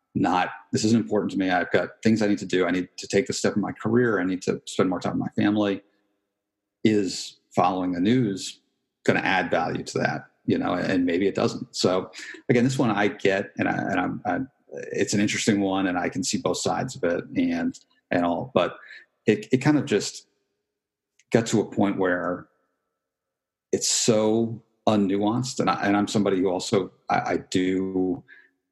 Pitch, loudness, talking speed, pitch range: 100 Hz, -24 LUFS, 205 wpm, 90-110 Hz